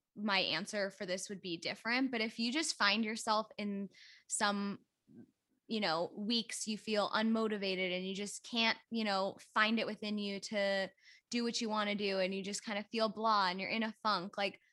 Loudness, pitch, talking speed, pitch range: -36 LUFS, 205 Hz, 210 wpm, 195-220 Hz